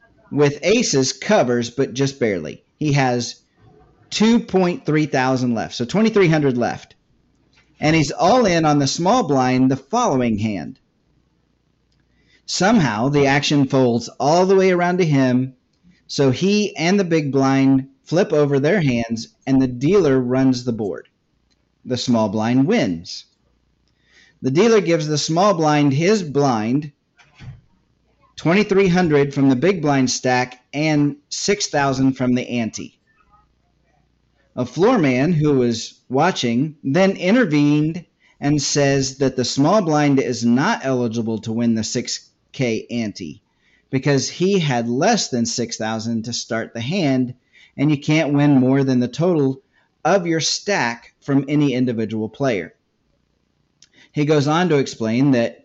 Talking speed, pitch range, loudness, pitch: 135 wpm, 125-155 Hz, -18 LUFS, 140 Hz